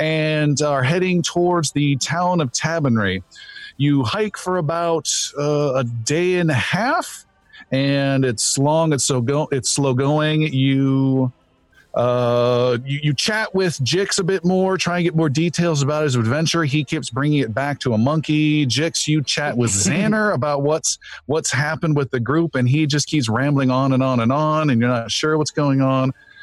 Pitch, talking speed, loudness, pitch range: 145 Hz, 185 wpm, -19 LUFS, 130-165 Hz